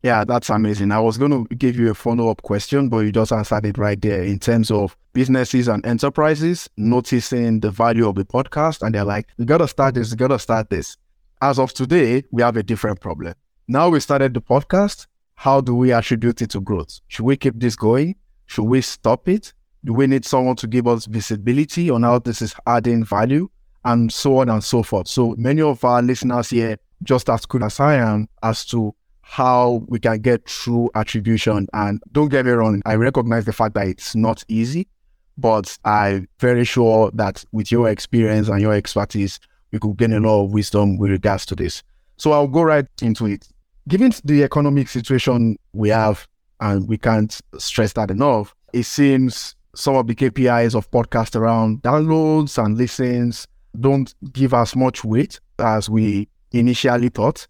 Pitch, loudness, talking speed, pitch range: 115 Hz, -18 LUFS, 195 wpm, 110-130 Hz